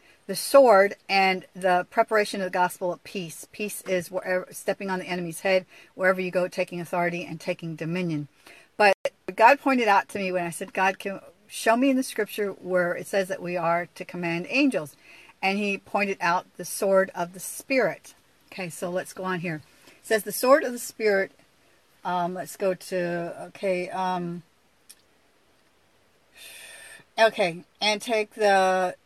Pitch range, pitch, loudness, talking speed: 180-205 Hz, 185 Hz, -25 LUFS, 170 wpm